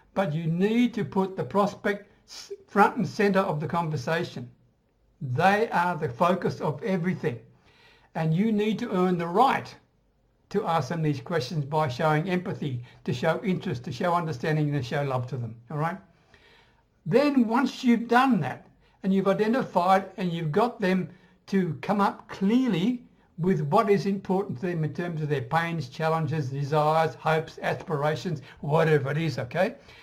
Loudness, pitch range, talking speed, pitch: -26 LUFS, 155-200 Hz, 165 wpm, 175 Hz